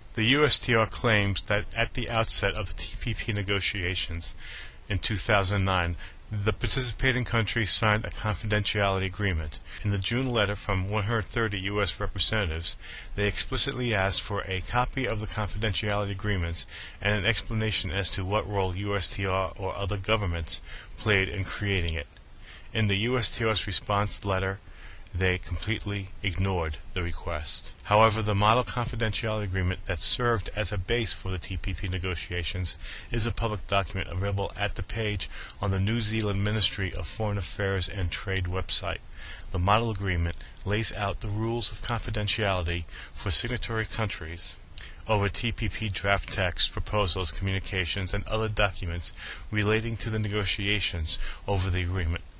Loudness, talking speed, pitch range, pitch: -27 LUFS, 140 wpm, 90-110 Hz, 100 Hz